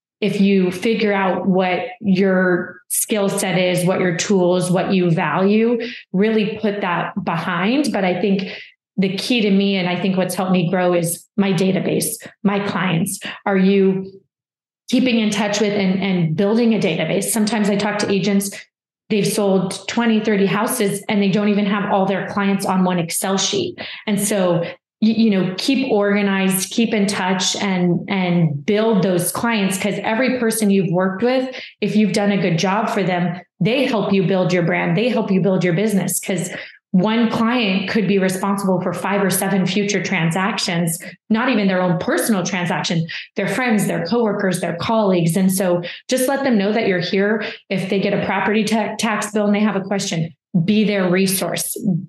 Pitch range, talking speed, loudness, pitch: 185-210 Hz, 185 wpm, -18 LUFS, 195 Hz